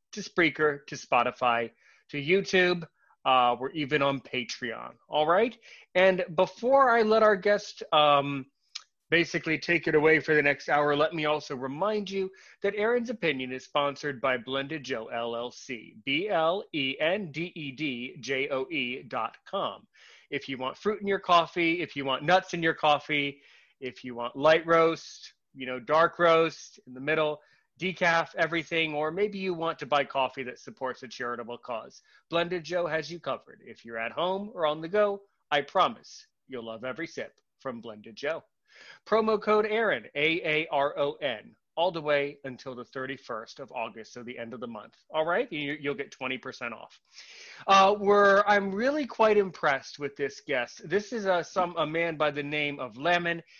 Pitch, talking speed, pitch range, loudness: 155 Hz, 175 wpm, 135-185 Hz, -27 LUFS